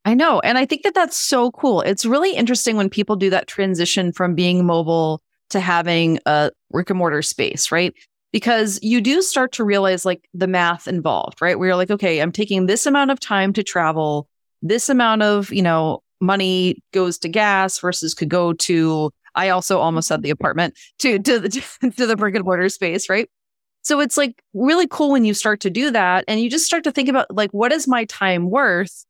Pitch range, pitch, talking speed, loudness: 180-240 Hz, 195 Hz, 215 wpm, -18 LUFS